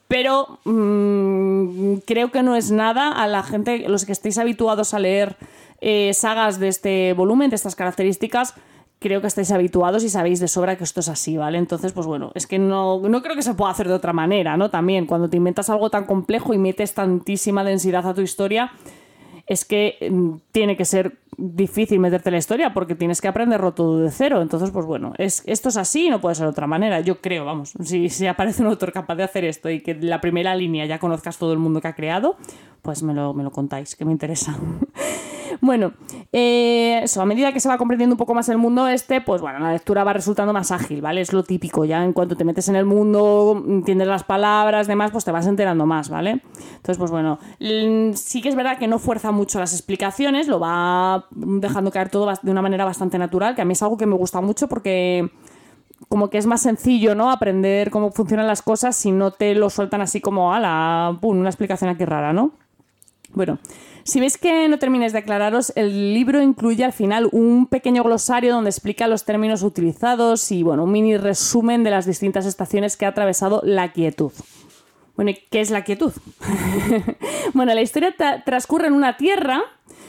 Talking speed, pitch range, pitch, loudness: 215 wpm, 180-230 Hz, 200 Hz, -19 LUFS